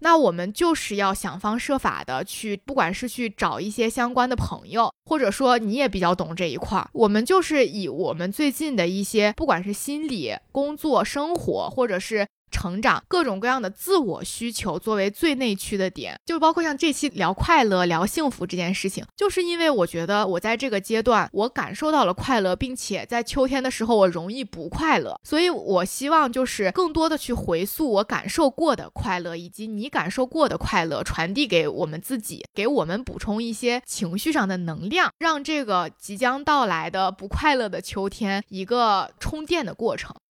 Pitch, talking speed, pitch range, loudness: 230 Hz, 295 characters per minute, 195-285 Hz, -23 LUFS